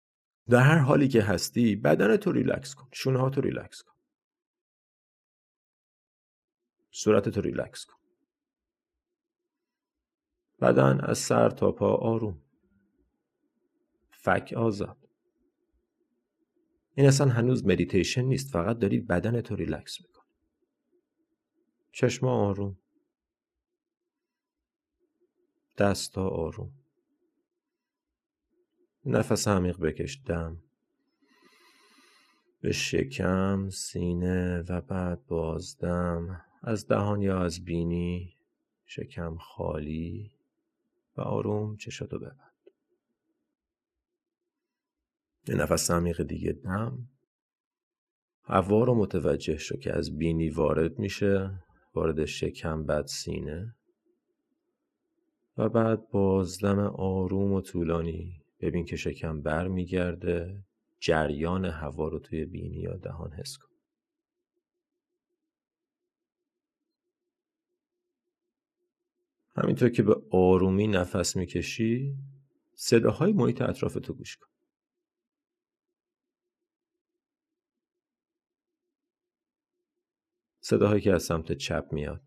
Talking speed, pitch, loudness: 85 wpm, 135 Hz, -28 LUFS